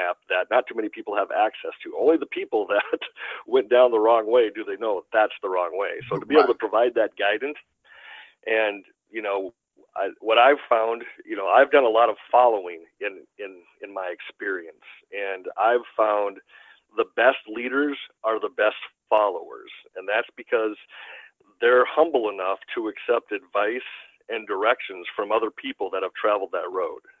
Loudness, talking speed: -23 LUFS, 175 wpm